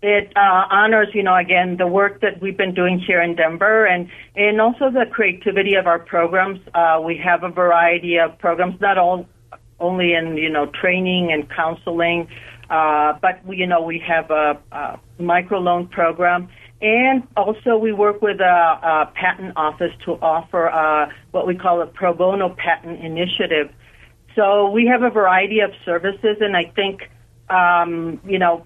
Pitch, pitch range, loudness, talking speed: 180 Hz, 165-195 Hz, -17 LUFS, 170 wpm